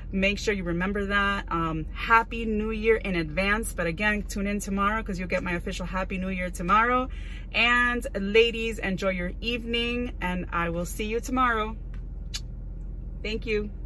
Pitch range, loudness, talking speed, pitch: 180-225 Hz, -26 LUFS, 165 wpm, 200 Hz